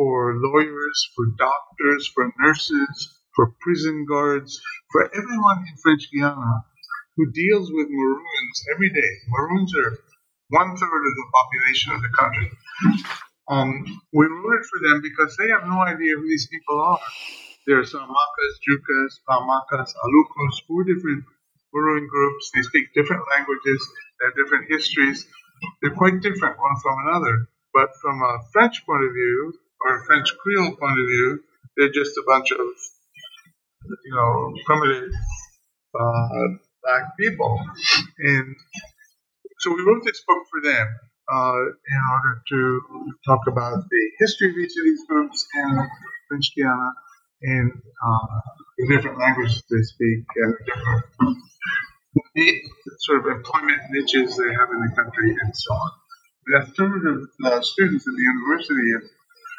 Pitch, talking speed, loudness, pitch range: 145 Hz, 145 wpm, -21 LUFS, 130-205 Hz